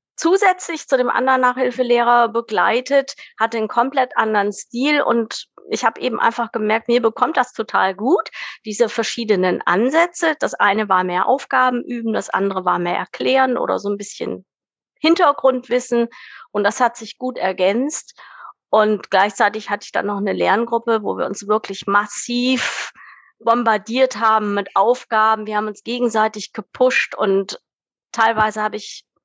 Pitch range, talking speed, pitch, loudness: 210-255 Hz, 150 wpm, 230 Hz, -18 LUFS